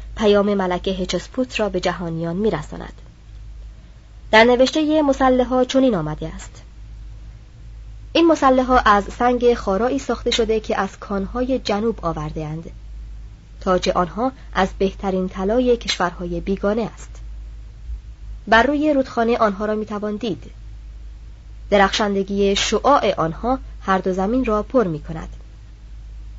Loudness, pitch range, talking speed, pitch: -19 LUFS, 170-240 Hz, 120 wpm, 200 Hz